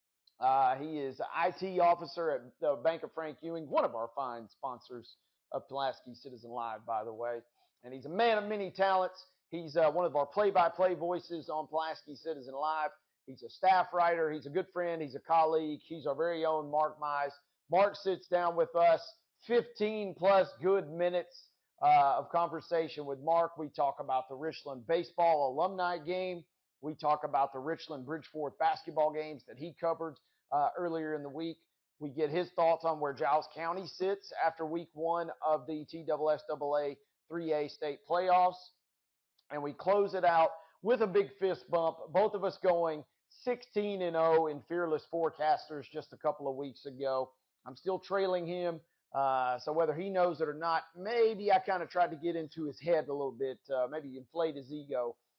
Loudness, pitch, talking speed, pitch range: -33 LUFS, 165 Hz, 185 wpm, 145-180 Hz